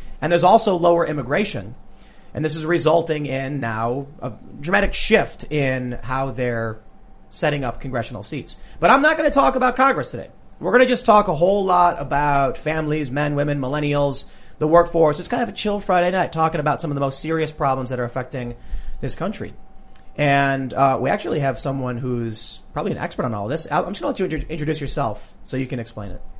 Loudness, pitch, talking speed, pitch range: -20 LUFS, 145 Hz, 205 wpm, 125-170 Hz